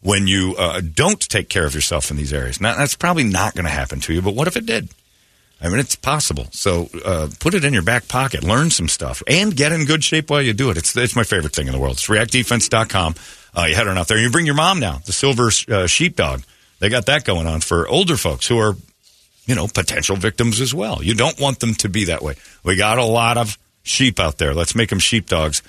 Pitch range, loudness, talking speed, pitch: 85-125 Hz, -17 LUFS, 260 wpm, 105 Hz